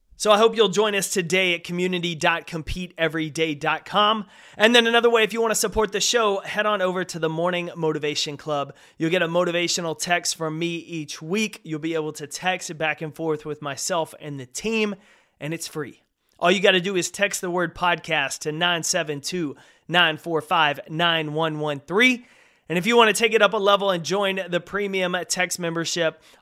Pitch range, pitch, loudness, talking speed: 160-200 Hz, 175 Hz, -22 LUFS, 190 wpm